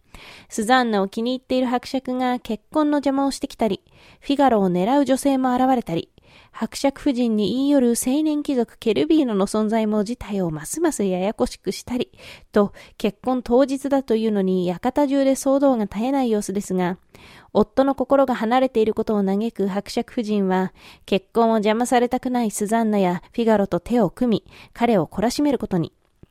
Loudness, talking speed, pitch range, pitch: -21 LUFS, 360 characters per minute, 205-265 Hz, 235 Hz